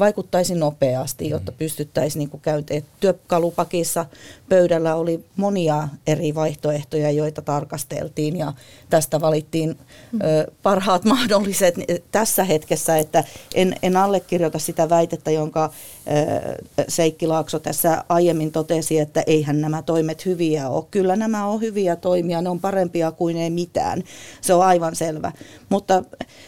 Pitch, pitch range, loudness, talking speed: 165 Hz, 155-180 Hz, -21 LUFS, 120 wpm